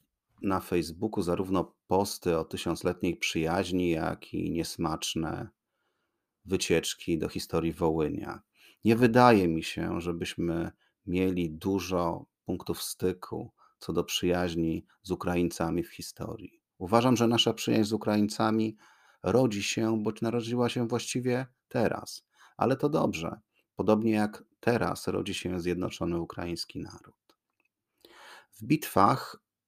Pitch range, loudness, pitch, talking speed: 85-110 Hz, -29 LUFS, 95 Hz, 115 wpm